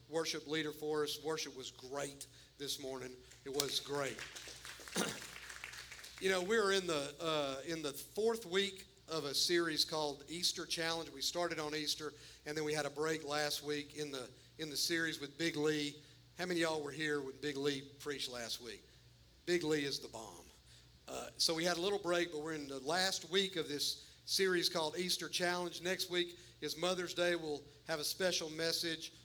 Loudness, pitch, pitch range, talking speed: -38 LUFS, 155 Hz, 140-170 Hz, 195 wpm